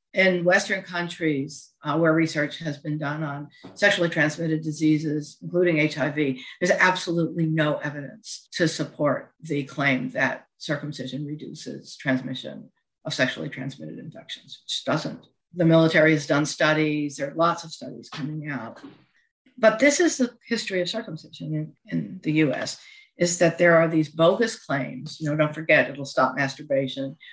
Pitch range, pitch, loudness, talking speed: 145-175 Hz, 155 Hz, -24 LUFS, 155 wpm